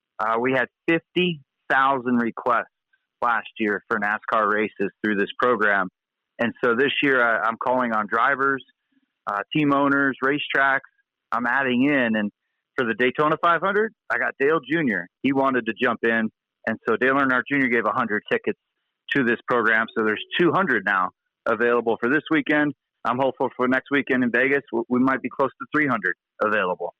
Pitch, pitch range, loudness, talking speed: 135 Hz, 120-150 Hz, -22 LUFS, 170 wpm